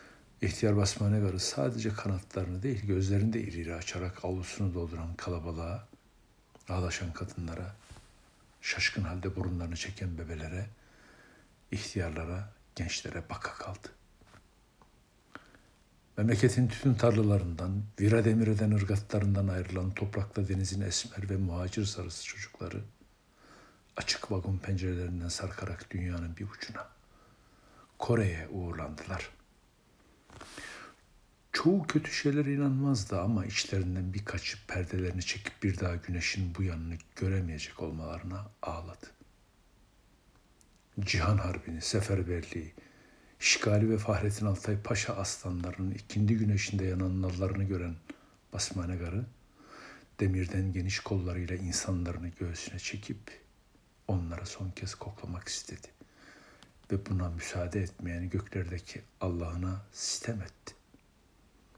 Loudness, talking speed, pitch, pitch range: -33 LUFS, 95 wpm, 95 Hz, 90-105 Hz